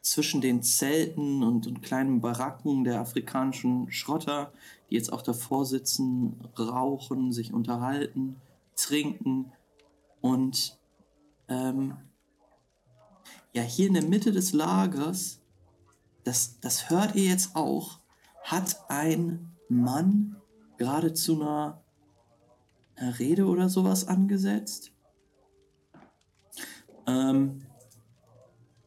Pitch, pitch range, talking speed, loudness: 135 Hz, 120-155 Hz, 95 wpm, -28 LUFS